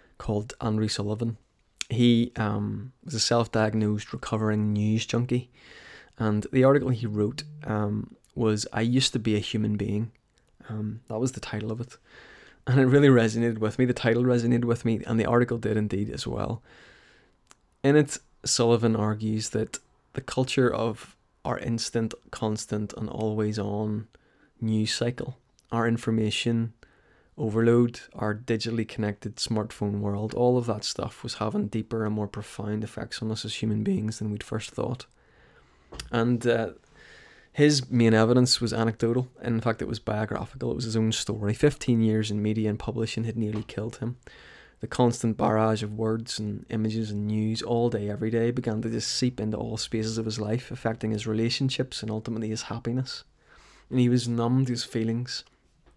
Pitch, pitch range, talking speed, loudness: 115 Hz, 110-120 Hz, 170 wpm, -27 LUFS